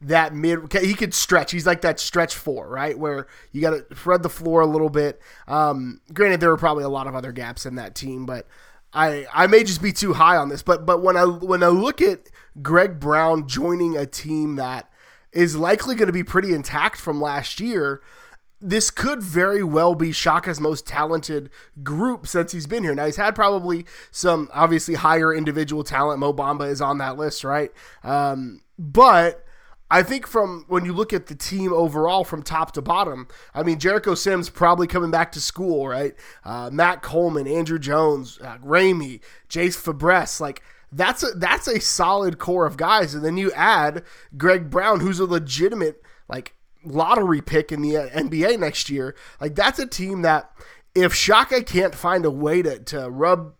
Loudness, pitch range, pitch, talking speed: -20 LUFS, 150-180 Hz, 165 Hz, 190 wpm